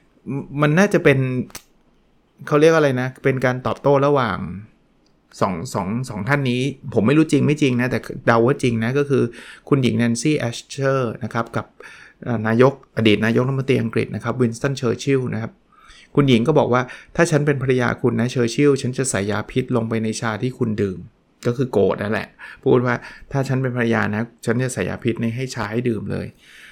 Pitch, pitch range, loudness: 125 Hz, 115-135 Hz, -20 LUFS